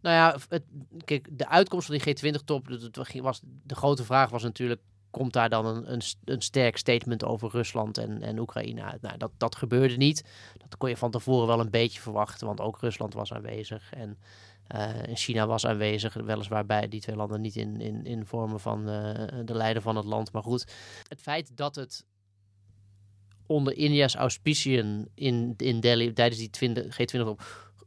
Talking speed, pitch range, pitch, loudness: 185 wpm, 105-130 Hz, 115 Hz, -29 LUFS